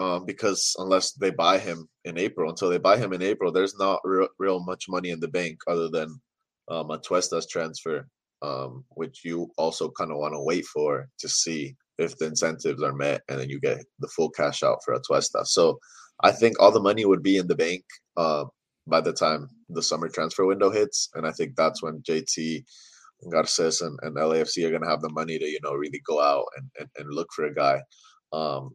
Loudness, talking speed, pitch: -25 LUFS, 220 wpm, 85 Hz